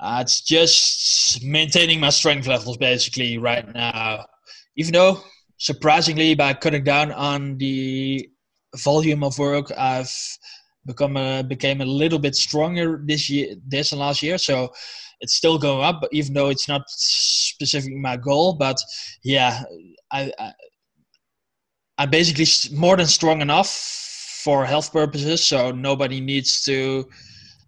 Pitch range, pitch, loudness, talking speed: 130-155 Hz, 140 Hz, -19 LUFS, 140 wpm